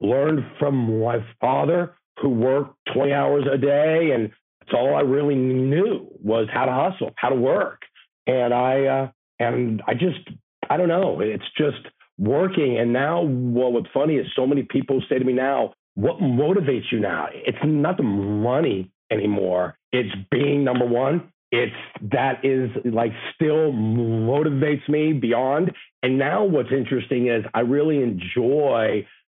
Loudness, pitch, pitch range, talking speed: -22 LUFS, 130 Hz, 120-145 Hz, 155 wpm